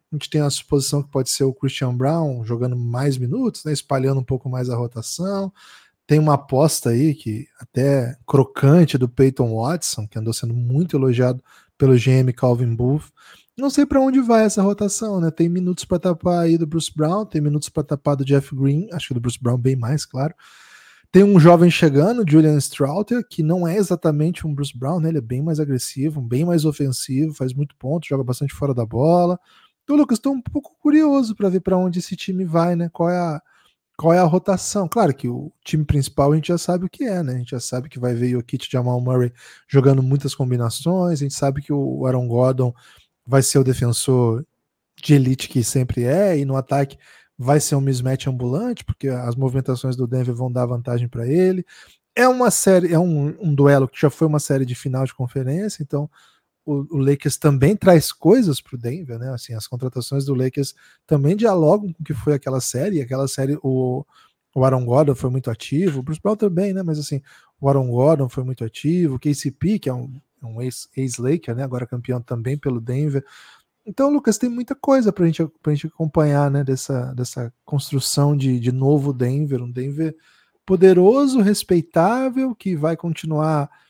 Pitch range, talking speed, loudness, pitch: 130-170 Hz, 200 wpm, -19 LUFS, 145 Hz